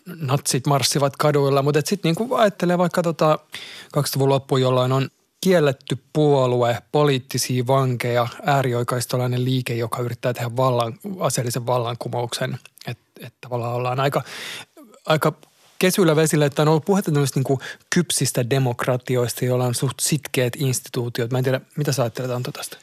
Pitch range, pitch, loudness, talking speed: 125-150 Hz, 135 Hz, -21 LUFS, 135 wpm